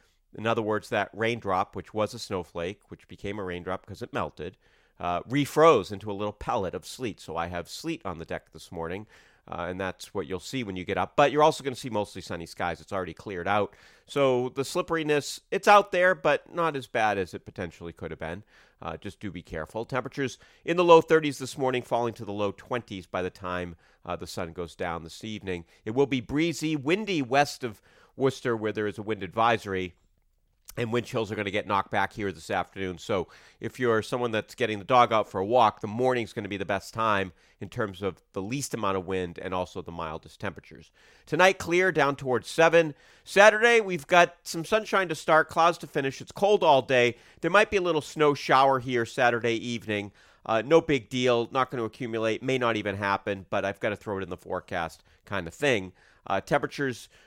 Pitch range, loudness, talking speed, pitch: 95-140 Hz, -27 LUFS, 225 wpm, 115 Hz